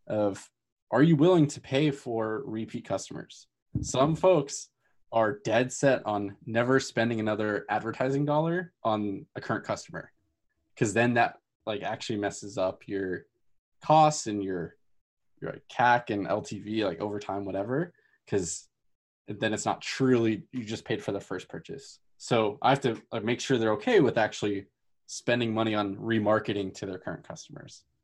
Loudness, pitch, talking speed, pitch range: -28 LUFS, 110 Hz, 160 wpm, 100-130 Hz